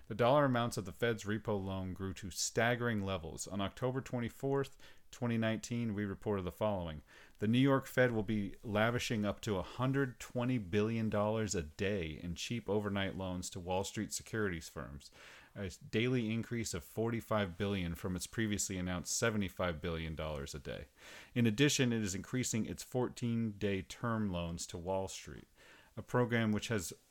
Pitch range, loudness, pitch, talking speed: 95-115 Hz, -37 LUFS, 105 Hz, 160 wpm